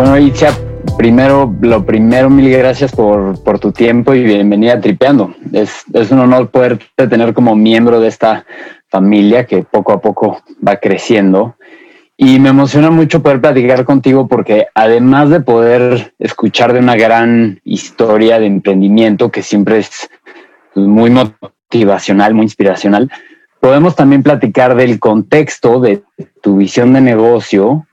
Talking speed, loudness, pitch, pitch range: 145 wpm, -9 LUFS, 120 Hz, 110-130 Hz